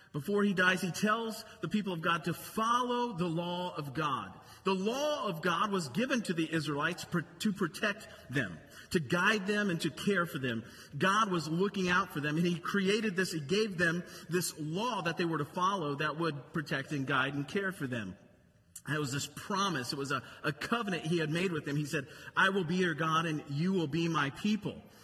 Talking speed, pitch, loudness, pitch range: 220 wpm, 175 Hz, -33 LUFS, 155-200 Hz